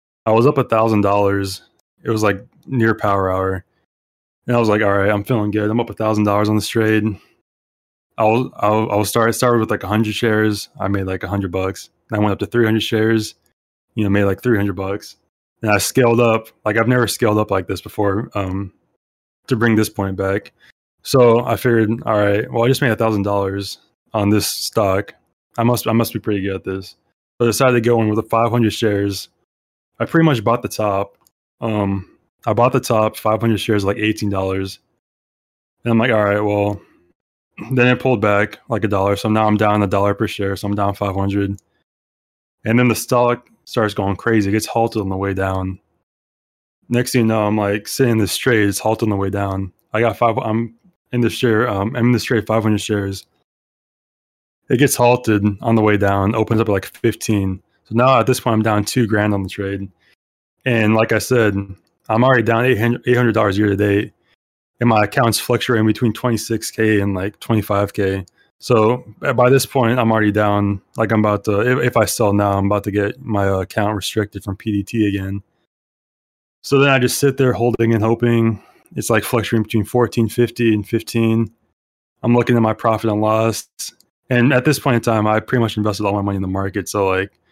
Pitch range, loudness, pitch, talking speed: 100-115 Hz, -17 LUFS, 110 Hz, 215 wpm